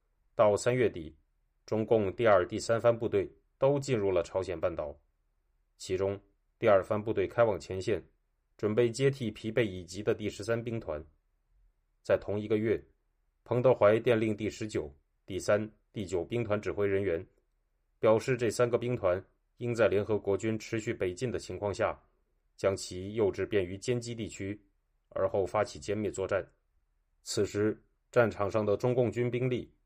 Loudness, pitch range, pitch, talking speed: -31 LUFS, 85-120 Hz, 105 Hz, 240 characters per minute